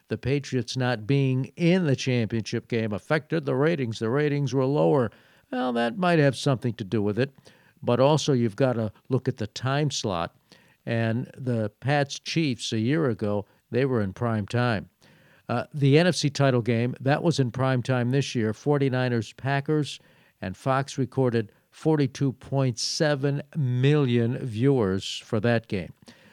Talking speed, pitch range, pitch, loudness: 155 wpm, 115-145 Hz, 130 Hz, -25 LUFS